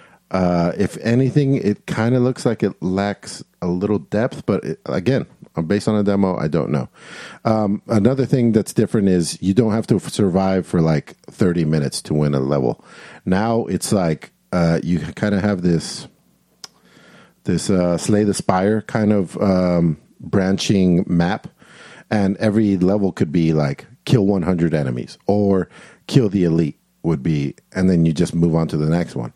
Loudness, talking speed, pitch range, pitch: -19 LUFS, 180 wpm, 85-105 Hz, 95 Hz